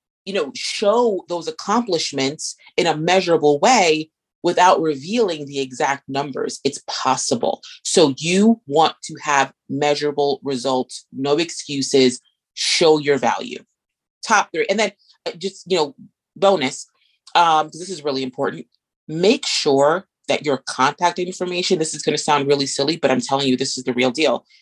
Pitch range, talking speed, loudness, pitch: 140-180 Hz, 155 wpm, -19 LUFS, 155 Hz